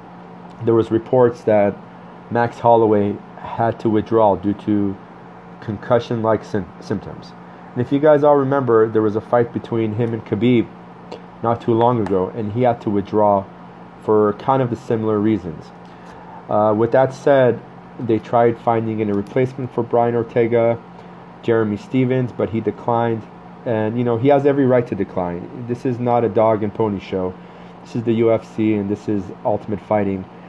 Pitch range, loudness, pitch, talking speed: 100-120 Hz, -18 LUFS, 110 Hz, 170 wpm